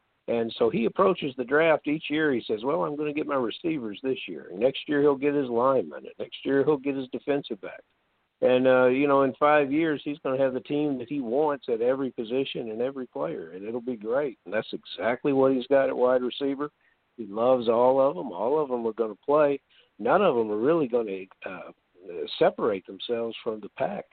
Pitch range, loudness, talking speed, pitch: 125-150 Hz, -26 LUFS, 230 wpm, 135 Hz